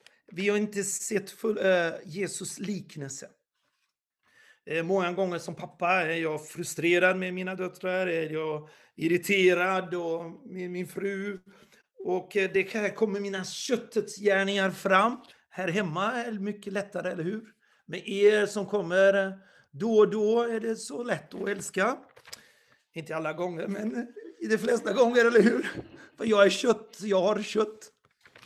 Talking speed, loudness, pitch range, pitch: 140 wpm, -28 LUFS, 180-210 Hz, 195 Hz